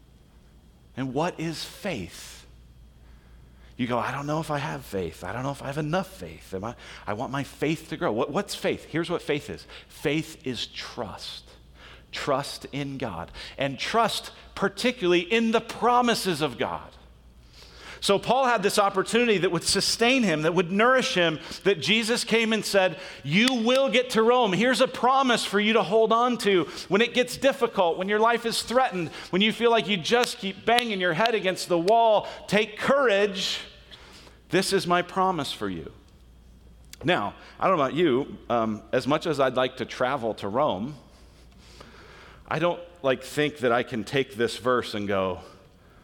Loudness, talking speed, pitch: -25 LUFS, 180 wpm, 165 Hz